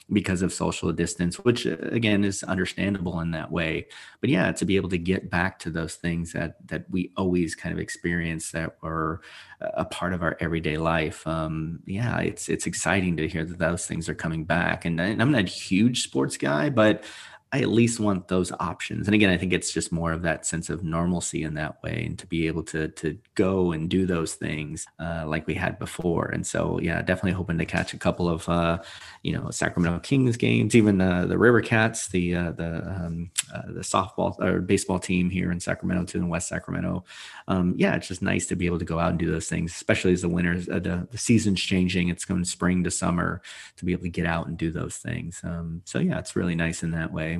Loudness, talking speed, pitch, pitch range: -26 LUFS, 235 wpm, 85 Hz, 85-95 Hz